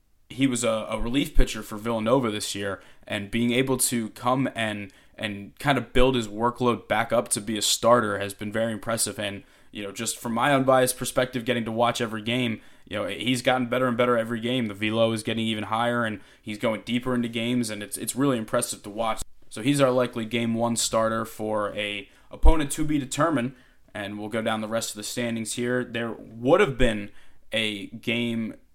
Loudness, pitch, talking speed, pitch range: -26 LUFS, 115 Hz, 215 wpm, 110-125 Hz